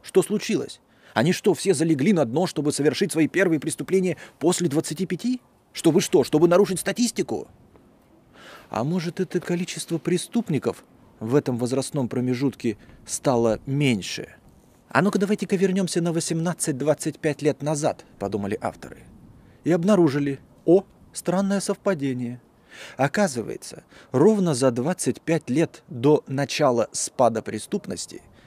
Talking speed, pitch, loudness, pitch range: 120 wpm, 165 Hz, -23 LUFS, 140-185 Hz